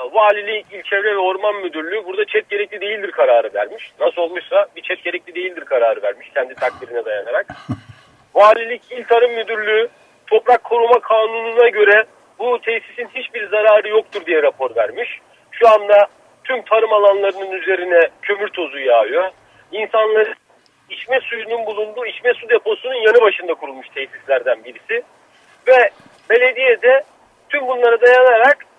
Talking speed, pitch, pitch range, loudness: 135 wpm, 225 Hz, 205-300 Hz, -16 LUFS